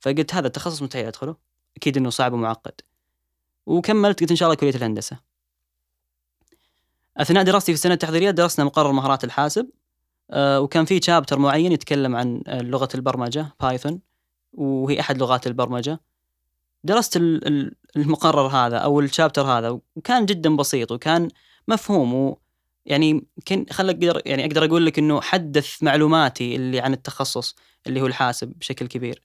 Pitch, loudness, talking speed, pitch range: 140 Hz, -21 LUFS, 140 wpm, 120-160 Hz